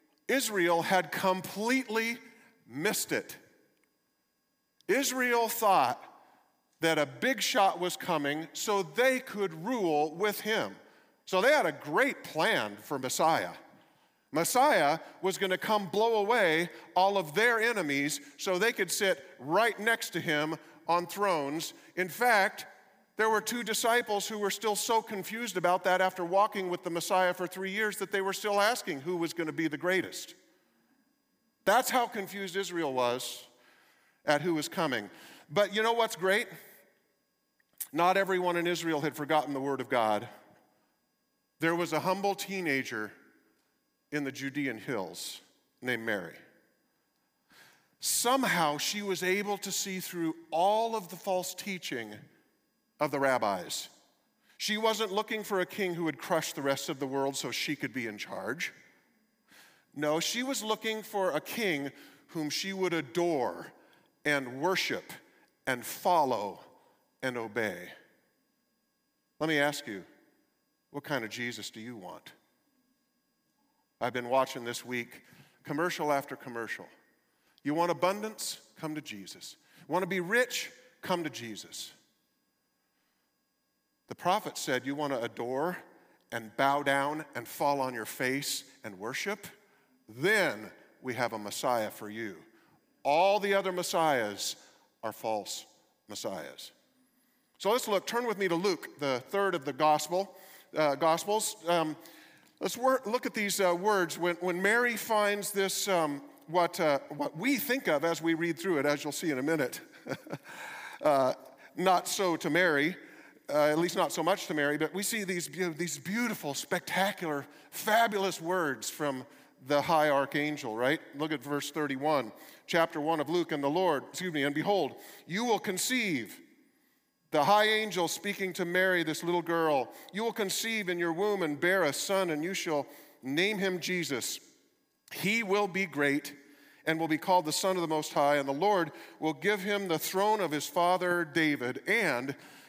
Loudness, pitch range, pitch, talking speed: -31 LUFS, 150-210 Hz, 180 Hz, 160 wpm